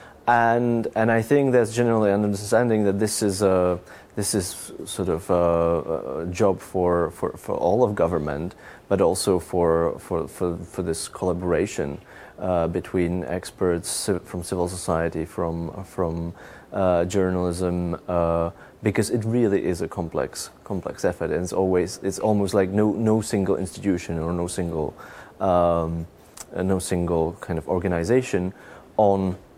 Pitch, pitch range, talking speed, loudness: 90 Hz, 85-105 Hz, 145 wpm, -24 LUFS